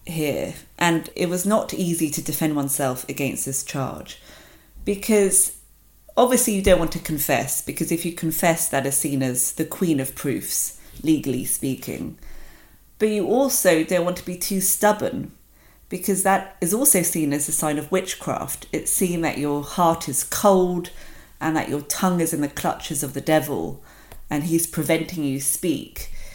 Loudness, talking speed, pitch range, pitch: -22 LUFS, 170 wpm, 145-185 Hz, 165 Hz